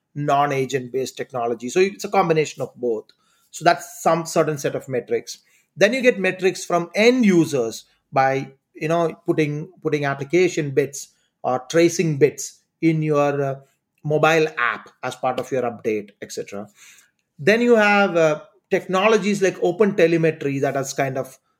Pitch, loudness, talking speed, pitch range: 160 Hz, -20 LUFS, 155 wpm, 140-185 Hz